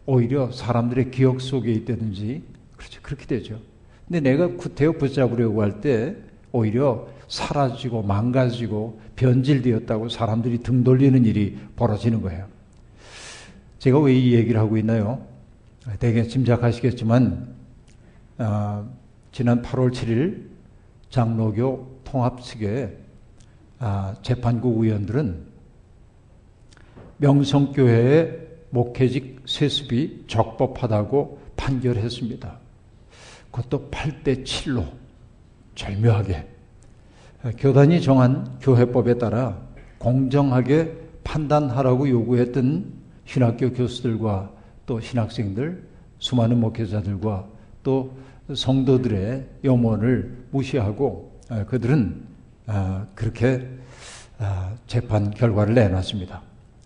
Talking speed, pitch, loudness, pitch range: 225 characters per minute, 120 Hz, -22 LUFS, 110-130 Hz